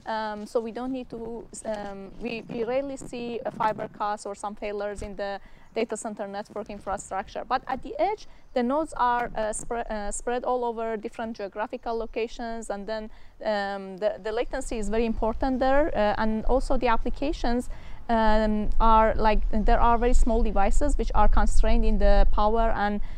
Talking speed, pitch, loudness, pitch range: 180 wpm, 225 Hz, -28 LUFS, 210-240 Hz